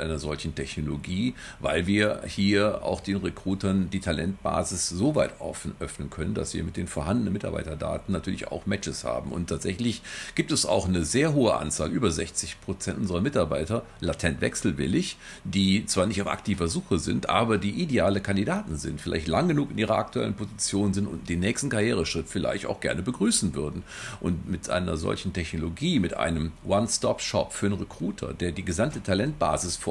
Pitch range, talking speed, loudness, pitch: 80-100 Hz, 175 wpm, -27 LUFS, 90 Hz